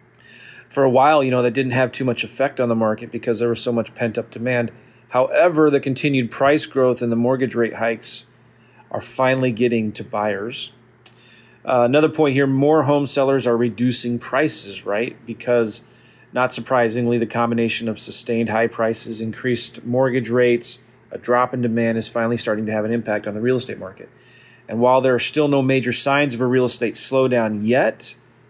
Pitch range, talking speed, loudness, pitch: 115-130 Hz, 190 wpm, -19 LUFS, 120 Hz